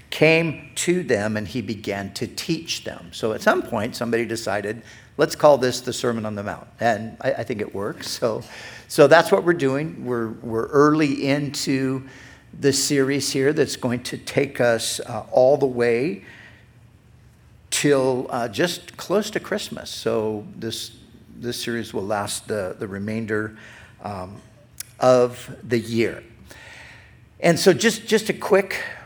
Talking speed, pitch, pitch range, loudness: 155 wpm, 120 Hz, 115-140 Hz, -22 LUFS